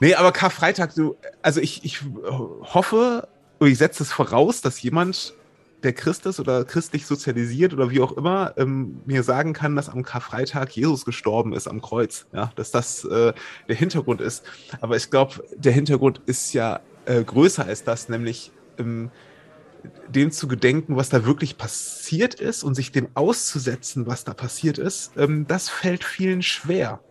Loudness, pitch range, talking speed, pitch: -22 LUFS, 125-170 Hz, 170 wpm, 140 Hz